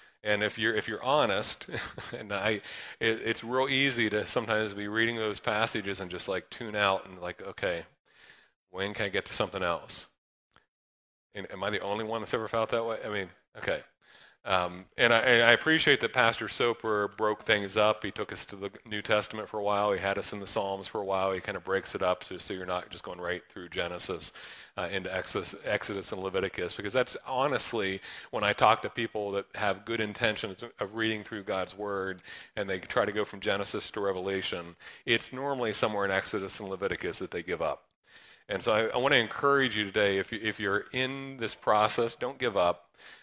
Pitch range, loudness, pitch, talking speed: 95-115 Hz, -30 LUFS, 105 Hz, 215 wpm